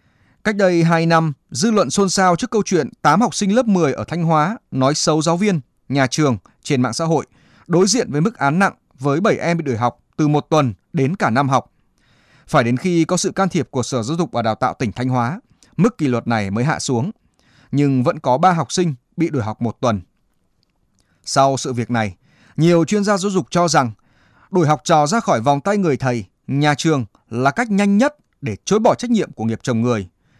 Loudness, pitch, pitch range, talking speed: -18 LUFS, 150 Hz, 125-180 Hz, 235 wpm